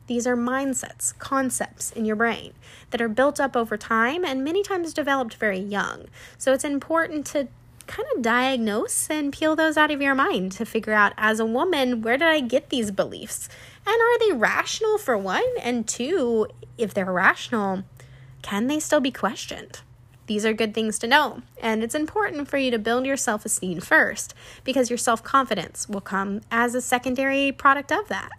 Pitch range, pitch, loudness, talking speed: 220-285 Hz, 245 Hz, -23 LUFS, 190 wpm